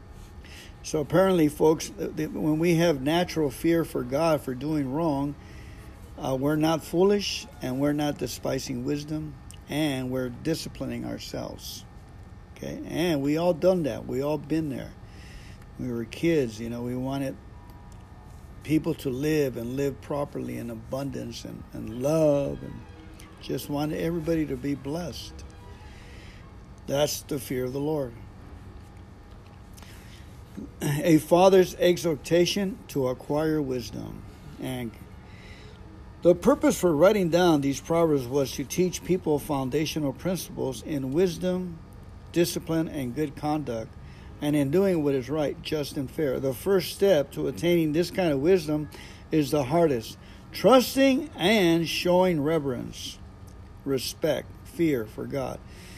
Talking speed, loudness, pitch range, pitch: 130 wpm, -26 LUFS, 105-165 Hz, 145 Hz